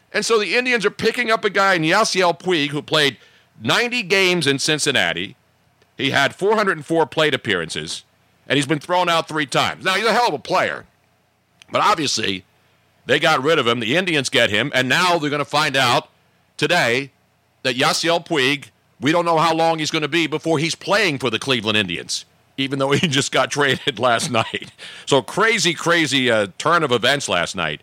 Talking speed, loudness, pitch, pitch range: 200 wpm, -18 LUFS, 155 Hz, 135-175 Hz